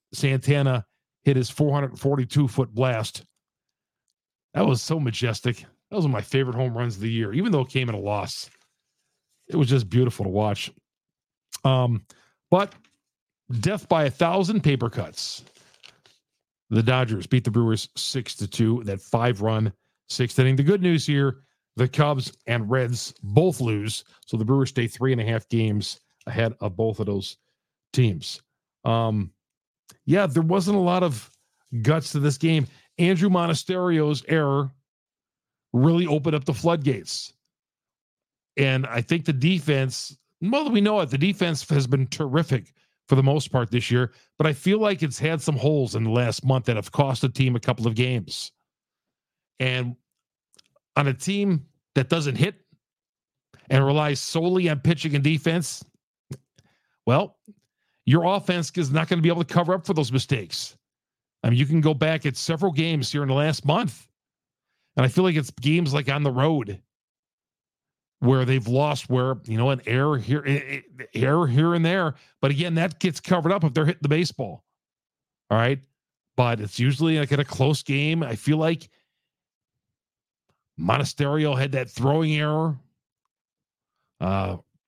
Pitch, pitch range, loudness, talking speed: 140 Hz, 125-160 Hz, -23 LUFS, 165 wpm